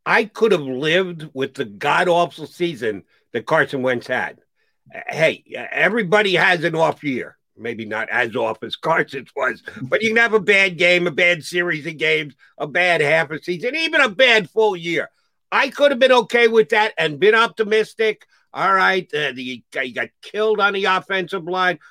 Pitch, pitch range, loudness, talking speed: 180 Hz, 155-220 Hz, -18 LUFS, 190 wpm